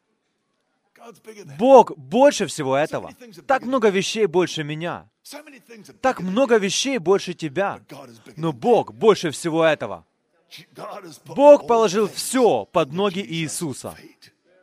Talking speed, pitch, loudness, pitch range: 105 wpm, 200 Hz, -19 LUFS, 165-235 Hz